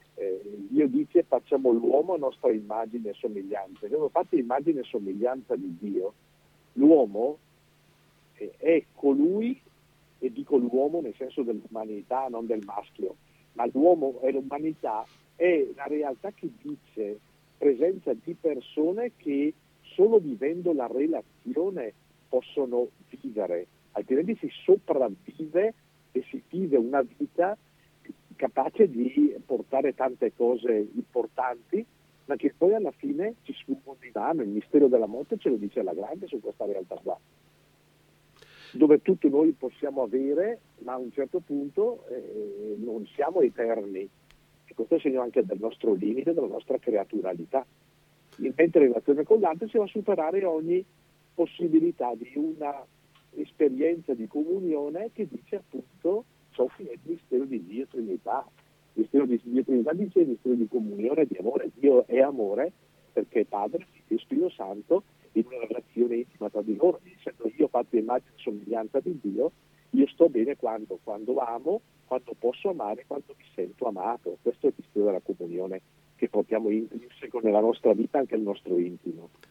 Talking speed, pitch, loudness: 150 wpm, 160 Hz, -27 LUFS